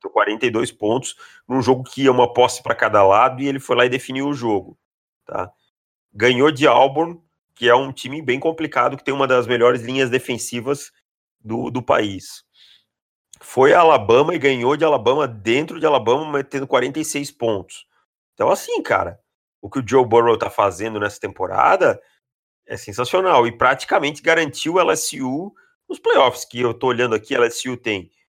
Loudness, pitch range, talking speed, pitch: -18 LUFS, 120-150 Hz, 170 wpm, 130 Hz